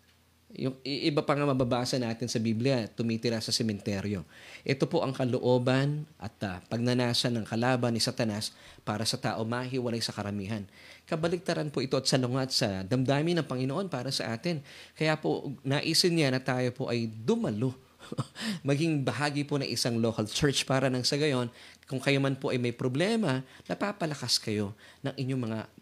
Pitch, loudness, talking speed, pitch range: 130 Hz, -30 LUFS, 170 wpm, 115-140 Hz